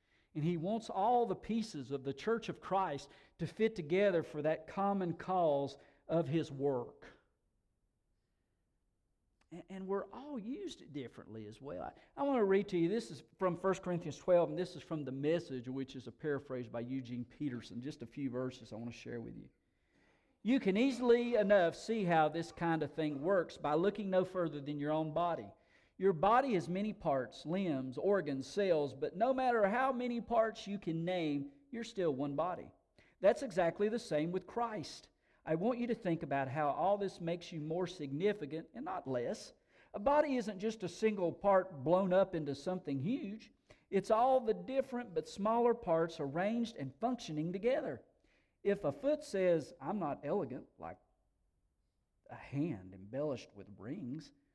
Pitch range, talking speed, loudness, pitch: 145-210 Hz, 180 wpm, -36 LUFS, 170 Hz